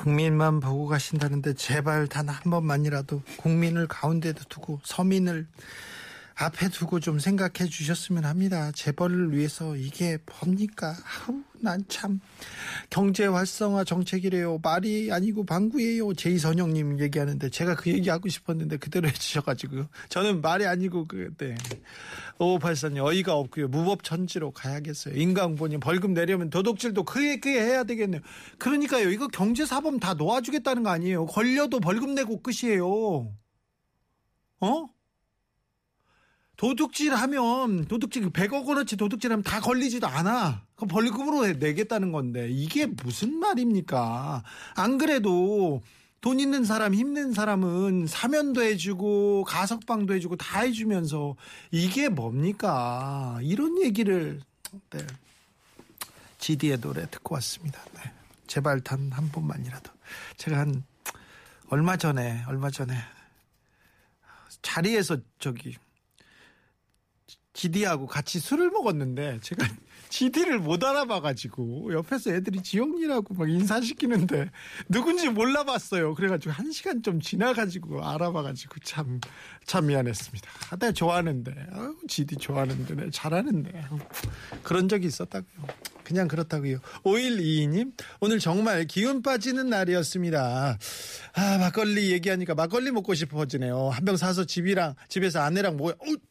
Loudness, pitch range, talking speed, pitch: -27 LUFS, 150-215 Hz, 305 characters per minute, 180 Hz